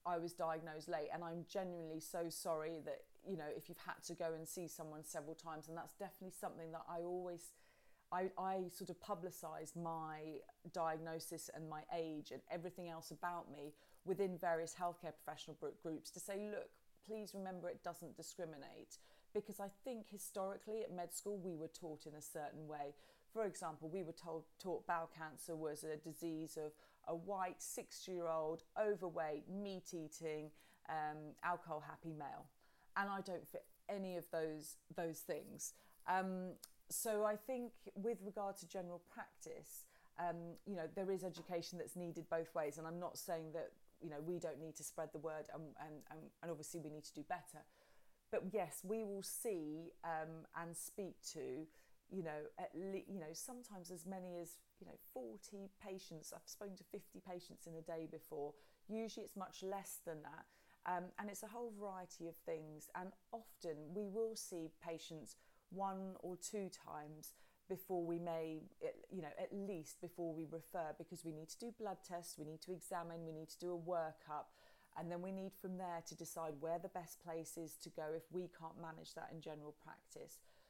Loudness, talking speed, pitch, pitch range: -48 LUFS, 185 wpm, 170 Hz, 160-190 Hz